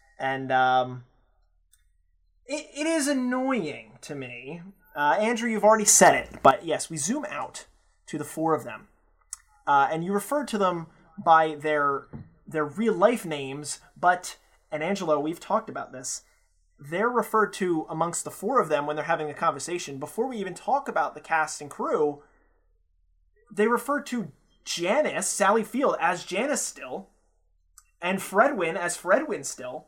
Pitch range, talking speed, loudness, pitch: 135-210 Hz, 160 wpm, -25 LUFS, 160 Hz